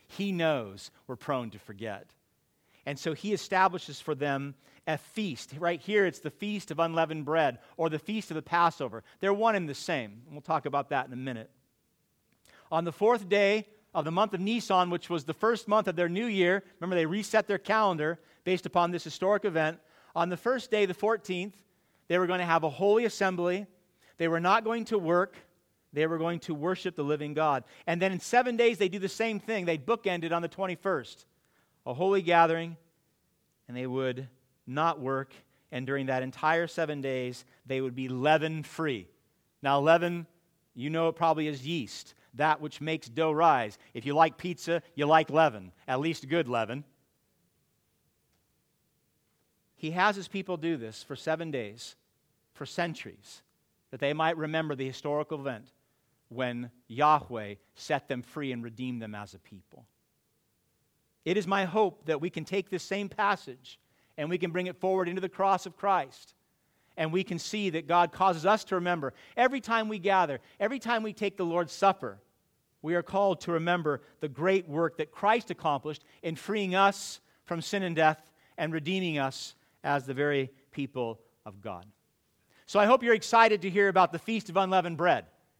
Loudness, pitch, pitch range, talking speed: -29 LUFS, 165 Hz, 145-190 Hz, 185 wpm